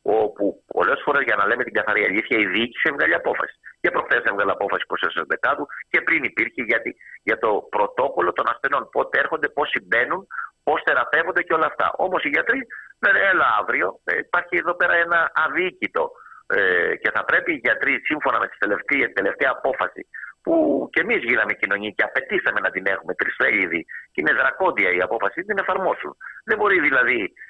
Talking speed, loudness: 175 wpm, -21 LUFS